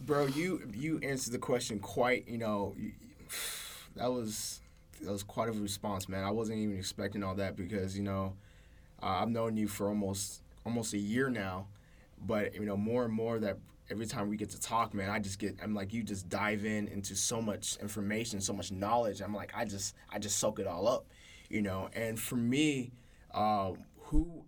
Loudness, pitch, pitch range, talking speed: -36 LUFS, 105 Hz, 100-115 Hz, 205 wpm